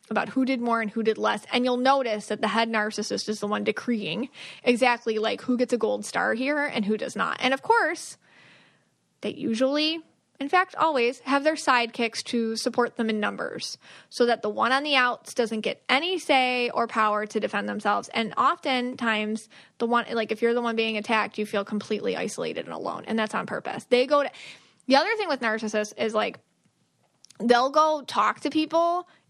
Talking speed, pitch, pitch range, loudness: 205 wpm, 240 Hz, 220-270 Hz, -25 LUFS